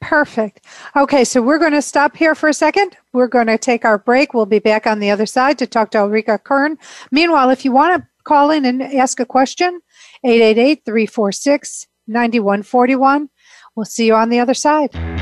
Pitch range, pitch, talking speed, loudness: 225-290 Hz, 255 Hz, 195 wpm, -14 LUFS